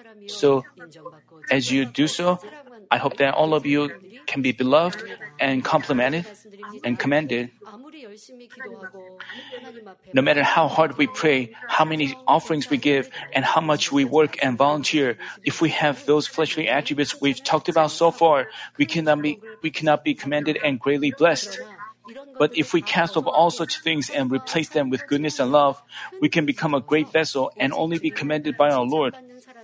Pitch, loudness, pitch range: 155 Hz, -21 LUFS, 145-175 Hz